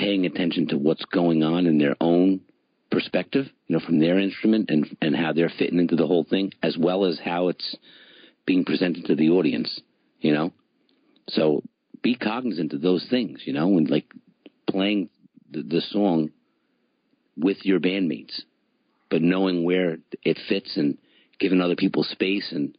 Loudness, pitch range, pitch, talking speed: -23 LUFS, 85-95 Hz, 90 Hz, 170 wpm